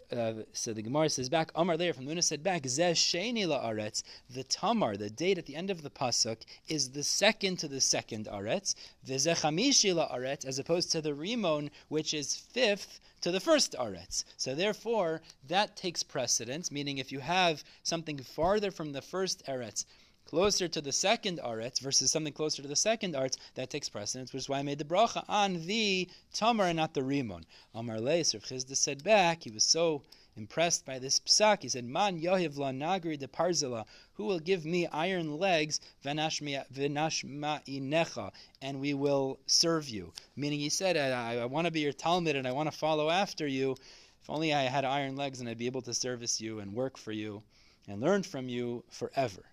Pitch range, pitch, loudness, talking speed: 130-170 Hz, 145 Hz, -31 LUFS, 195 wpm